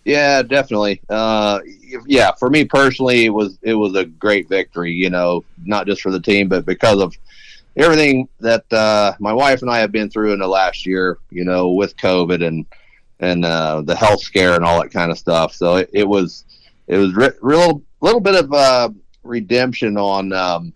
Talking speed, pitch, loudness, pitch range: 200 wpm, 105 Hz, -15 LUFS, 90-120 Hz